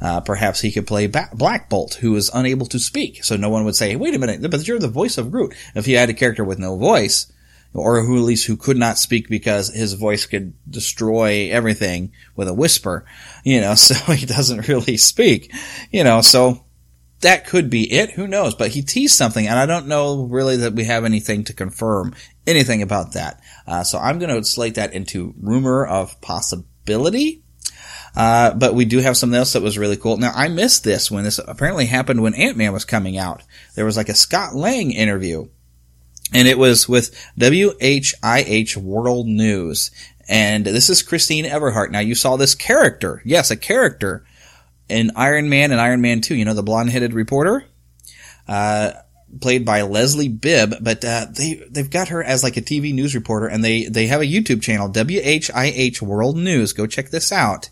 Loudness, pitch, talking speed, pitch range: -16 LUFS, 115 Hz, 205 wpm, 105-130 Hz